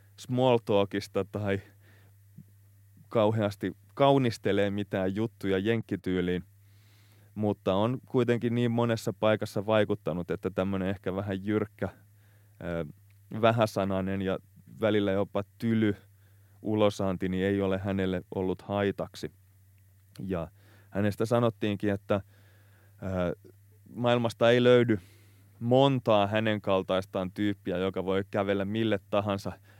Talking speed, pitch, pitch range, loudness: 95 wpm, 100 Hz, 95-110 Hz, -29 LUFS